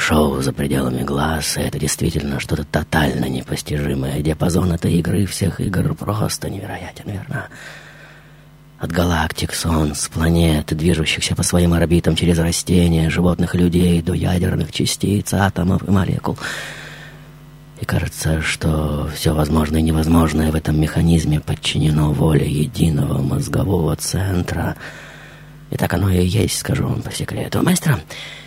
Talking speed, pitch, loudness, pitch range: 130 wpm, 85 Hz, -18 LUFS, 80-95 Hz